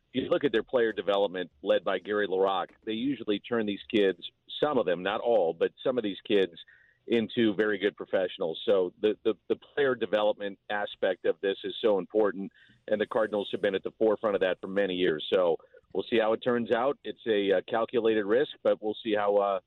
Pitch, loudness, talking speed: 145 Hz, -29 LUFS, 215 wpm